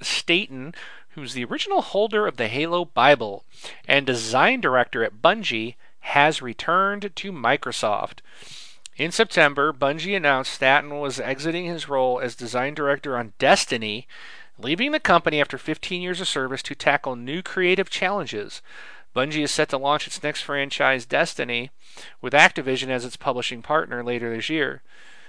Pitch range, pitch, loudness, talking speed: 130-175 Hz, 145 Hz, -22 LUFS, 150 wpm